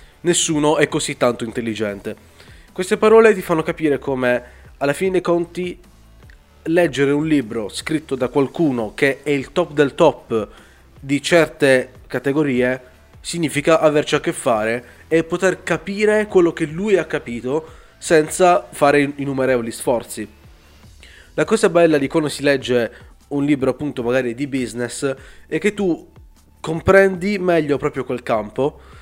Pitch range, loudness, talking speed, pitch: 120-170 Hz, -18 LUFS, 140 wpm, 145 Hz